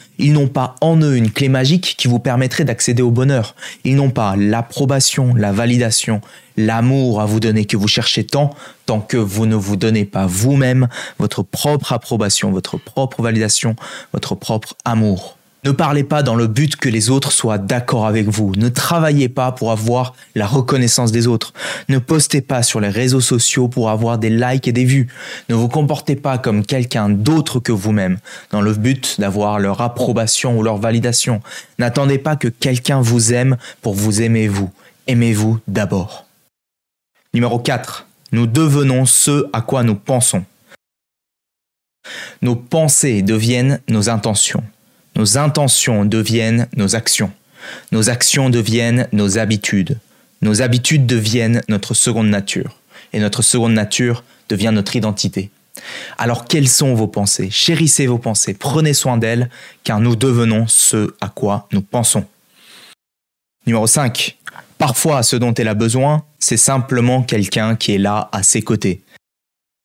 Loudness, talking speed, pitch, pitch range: -15 LUFS, 160 wpm, 120 Hz, 110-130 Hz